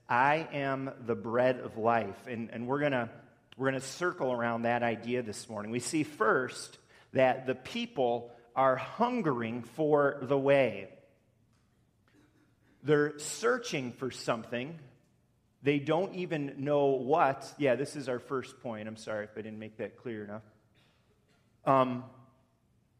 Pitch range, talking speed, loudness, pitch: 115-140 Hz, 140 wpm, -32 LUFS, 130 Hz